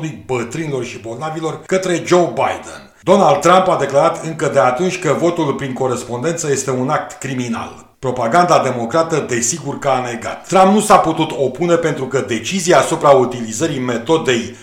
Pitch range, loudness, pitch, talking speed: 125-170 Hz, -16 LUFS, 150 Hz, 155 wpm